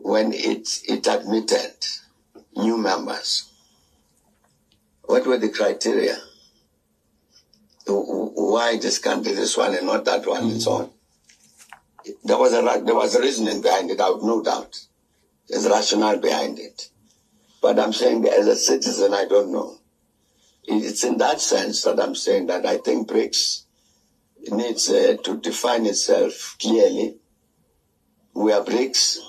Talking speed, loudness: 135 wpm, -21 LUFS